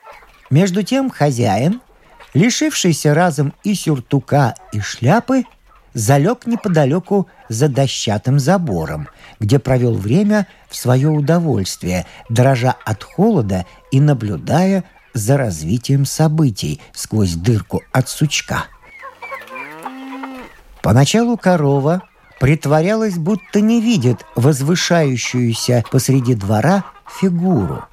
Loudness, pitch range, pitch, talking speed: -16 LUFS, 125-190 Hz, 145 Hz, 90 wpm